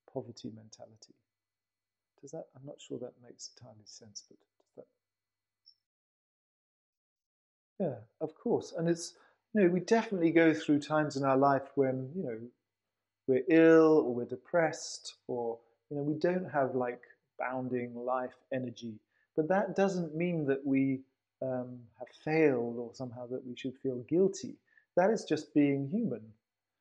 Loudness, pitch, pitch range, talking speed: -31 LUFS, 130 Hz, 115-155 Hz, 150 wpm